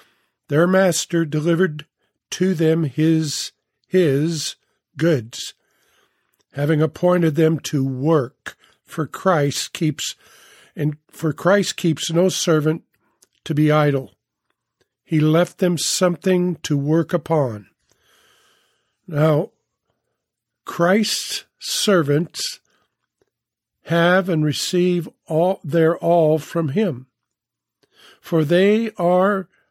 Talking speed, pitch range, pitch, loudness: 95 wpm, 150-180 Hz, 165 Hz, -19 LUFS